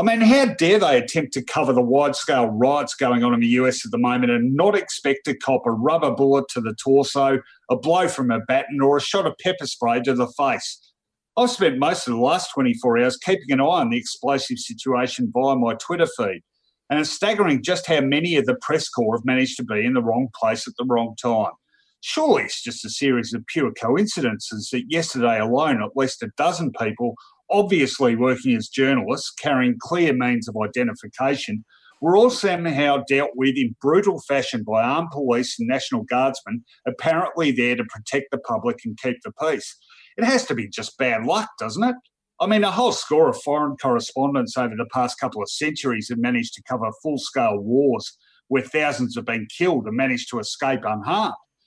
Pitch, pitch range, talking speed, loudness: 135 Hz, 125-175 Hz, 200 wpm, -21 LUFS